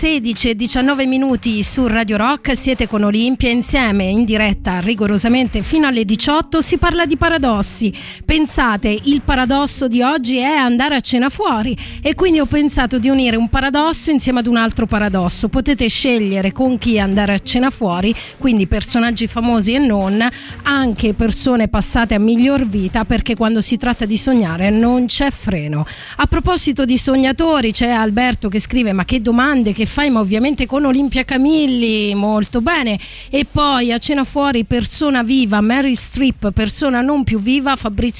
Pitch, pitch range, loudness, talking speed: 245 Hz, 220-275 Hz, -14 LUFS, 165 wpm